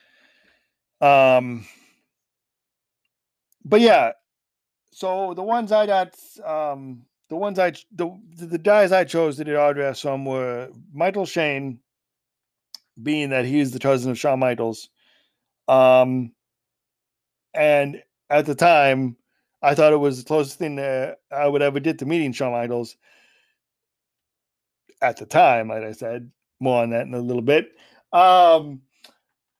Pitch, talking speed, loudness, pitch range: 140 Hz, 135 wpm, -20 LUFS, 130-165 Hz